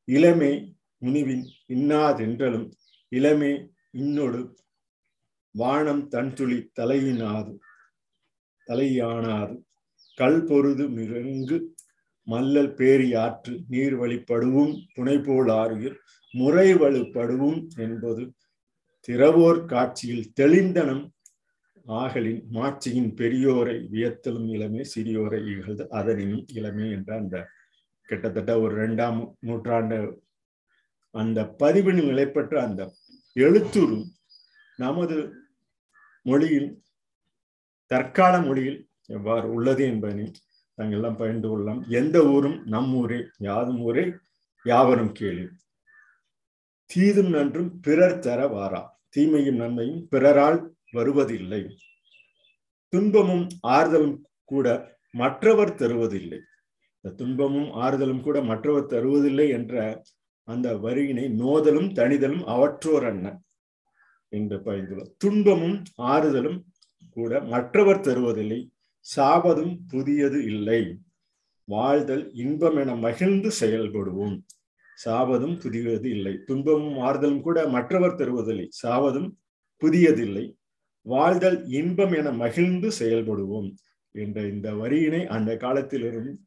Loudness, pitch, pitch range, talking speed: -24 LUFS, 130 Hz, 115-150 Hz, 85 wpm